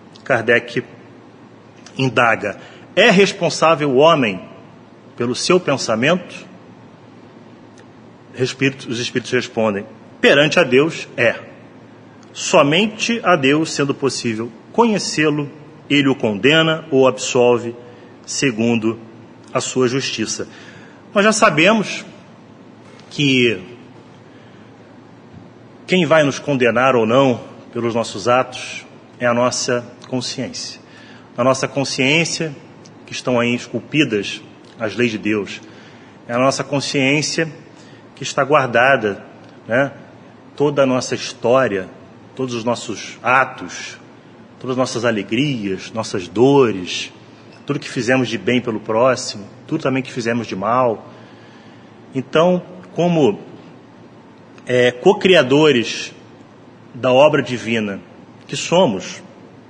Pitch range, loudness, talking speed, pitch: 120-145 Hz, -17 LUFS, 105 wpm, 130 Hz